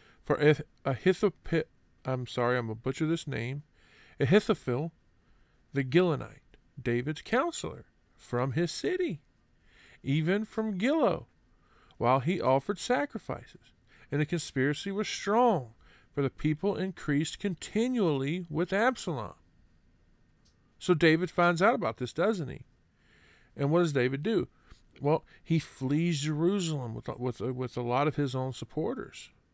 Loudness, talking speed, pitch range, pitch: -30 LUFS, 130 wpm, 125-180 Hz, 150 Hz